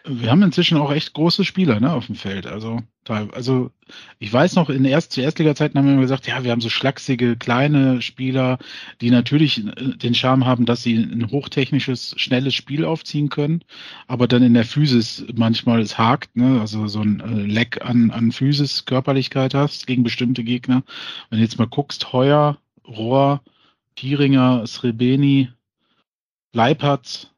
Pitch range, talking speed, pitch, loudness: 120-140 Hz, 165 wpm, 130 Hz, -18 LUFS